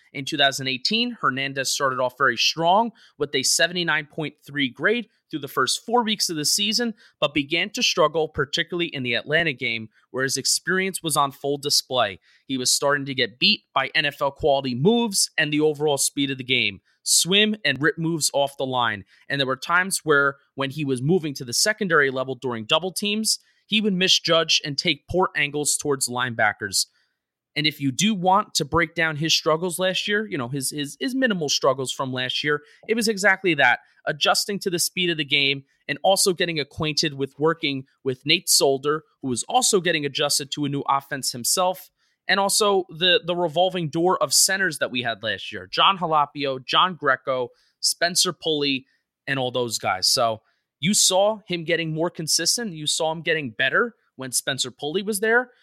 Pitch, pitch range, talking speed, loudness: 155 Hz, 135-185 Hz, 190 wpm, -22 LUFS